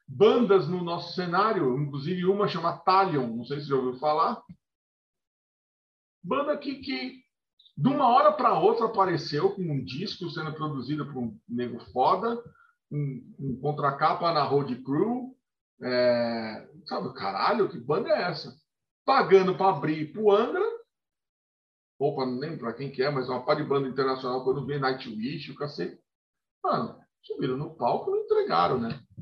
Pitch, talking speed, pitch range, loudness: 155 Hz, 160 wpm, 130-205 Hz, -27 LUFS